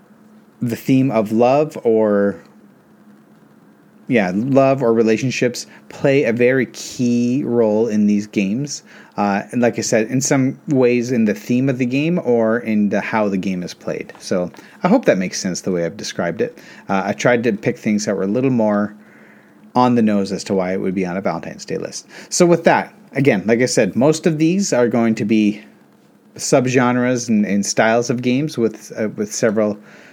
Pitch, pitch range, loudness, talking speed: 115 Hz, 105-130 Hz, -17 LUFS, 195 wpm